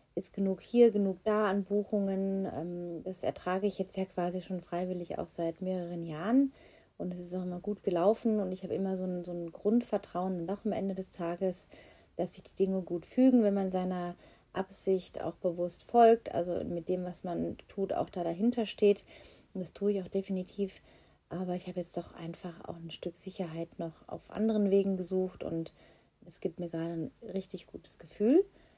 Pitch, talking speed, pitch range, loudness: 185 Hz, 195 wpm, 175-200 Hz, -33 LUFS